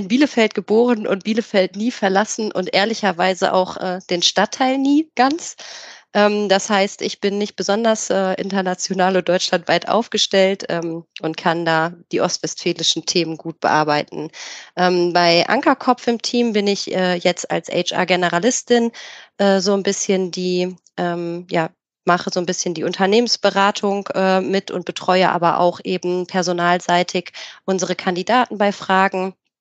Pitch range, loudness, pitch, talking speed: 180-205 Hz, -18 LUFS, 190 Hz, 145 wpm